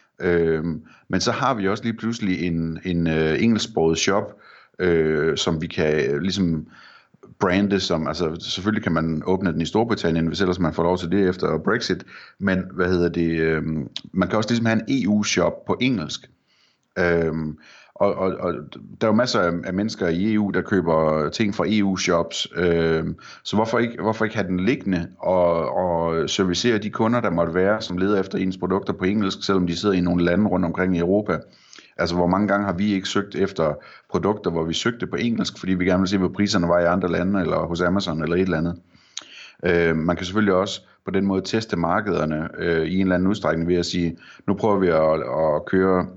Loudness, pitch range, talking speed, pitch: -22 LUFS, 85-100 Hz, 205 wpm, 90 Hz